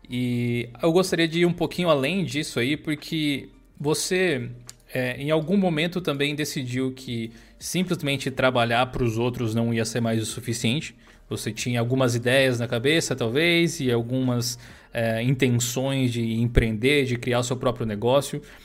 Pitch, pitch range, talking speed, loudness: 130 Hz, 120-150 Hz, 155 wpm, -24 LUFS